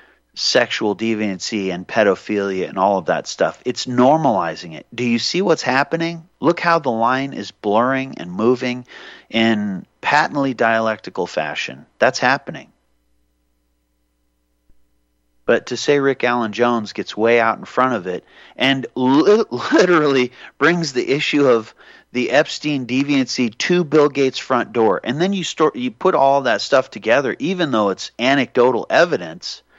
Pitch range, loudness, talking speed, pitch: 105-140 Hz, -18 LUFS, 150 wpm, 125 Hz